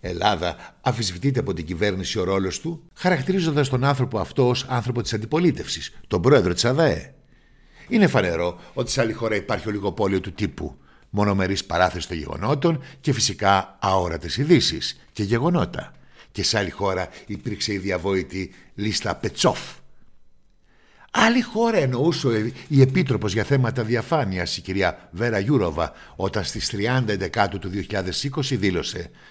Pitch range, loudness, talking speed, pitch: 95-135 Hz, -23 LUFS, 140 wpm, 105 Hz